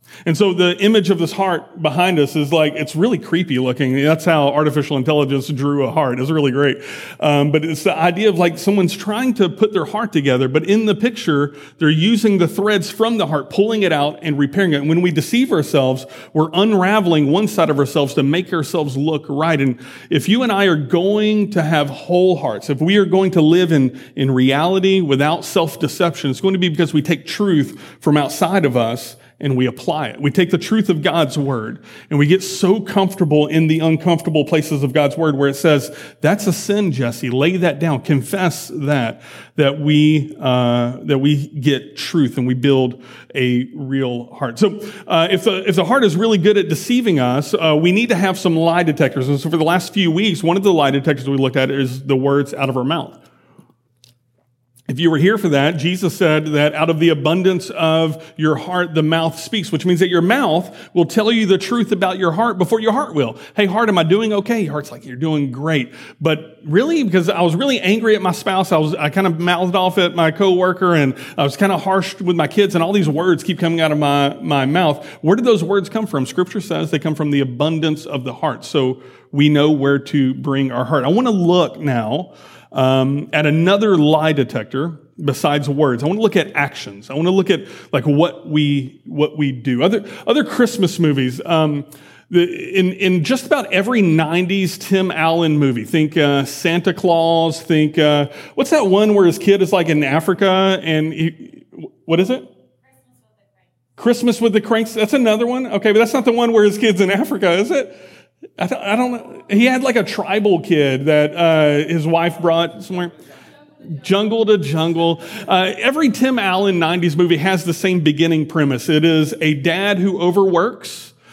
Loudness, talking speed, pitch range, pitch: -16 LUFS, 215 wpm, 145-190 Hz, 165 Hz